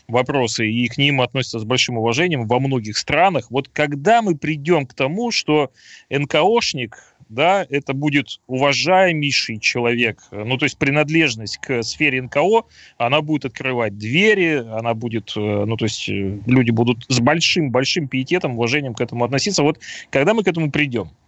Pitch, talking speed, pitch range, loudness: 135 Hz, 155 wpm, 120-150 Hz, -18 LUFS